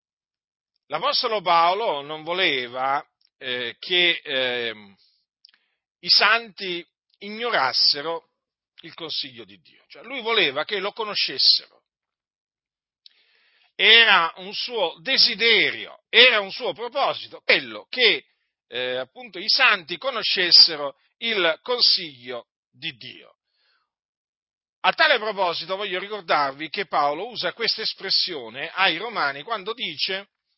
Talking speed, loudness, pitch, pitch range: 105 wpm, -20 LUFS, 190 Hz, 155-230 Hz